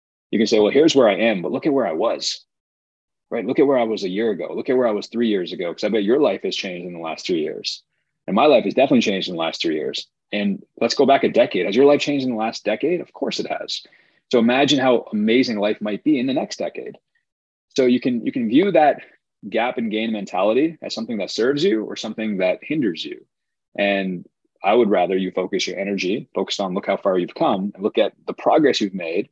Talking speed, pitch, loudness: 260 wpm, 115 Hz, -20 LUFS